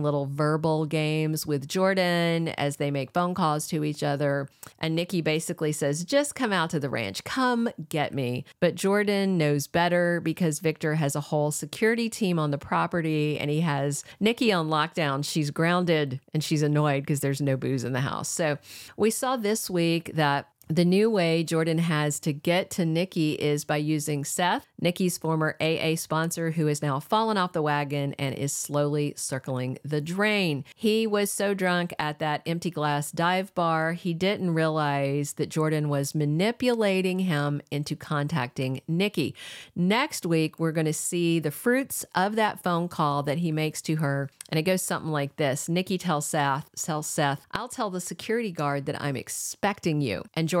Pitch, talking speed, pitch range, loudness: 160 Hz, 185 wpm, 145-175 Hz, -26 LUFS